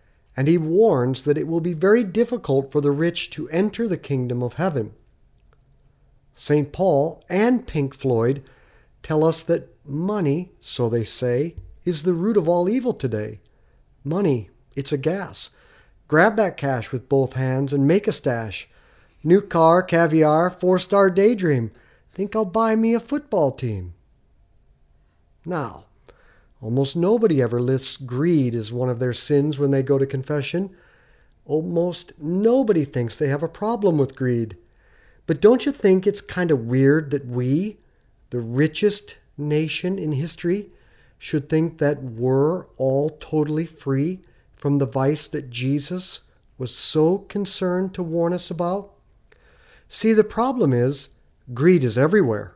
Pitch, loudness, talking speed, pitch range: 150 Hz, -21 LUFS, 150 wpm, 130-180 Hz